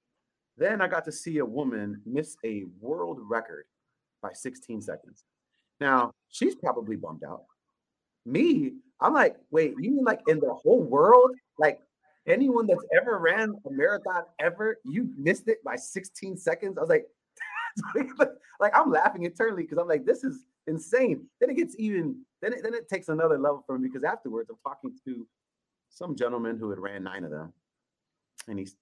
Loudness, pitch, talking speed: -27 LUFS, 215 Hz, 175 wpm